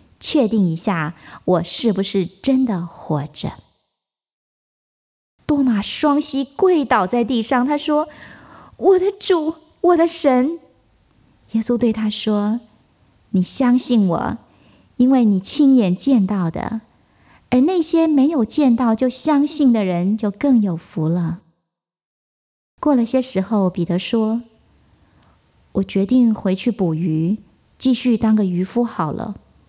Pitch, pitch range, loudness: 230 Hz, 190-270 Hz, -18 LUFS